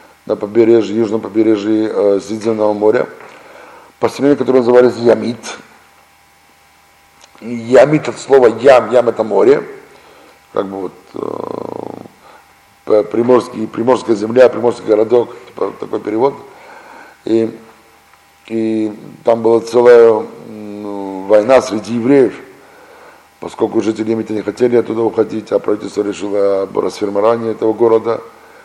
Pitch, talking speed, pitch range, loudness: 115 Hz, 105 wpm, 105-125 Hz, -13 LUFS